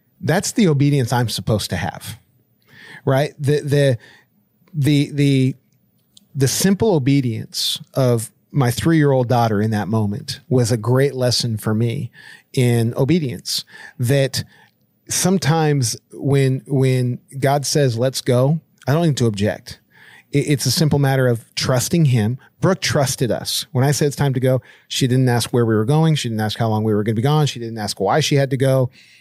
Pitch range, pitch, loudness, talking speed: 120-145 Hz, 135 Hz, -18 LUFS, 180 wpm